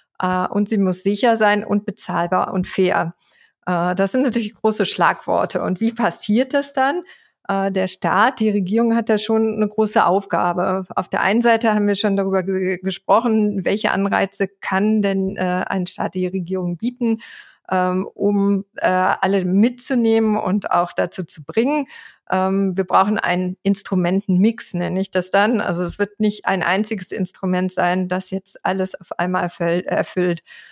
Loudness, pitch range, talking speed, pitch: -19 LUFS, 185-215 Hz, 170 wpm, 195 Hz